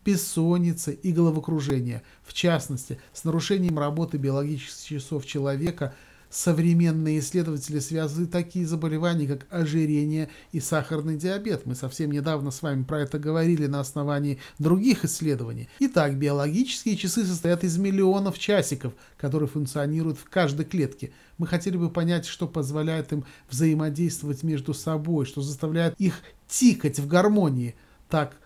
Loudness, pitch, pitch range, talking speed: -26 LUFS, 155 Hz, 145-170 Hz, 130 wpm